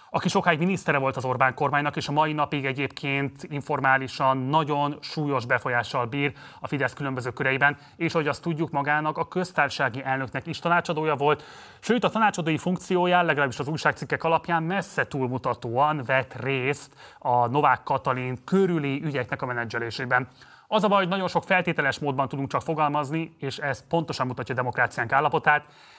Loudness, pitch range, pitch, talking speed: -25 LUFS, 130-160 Hz, 145 Hz, 160 wpm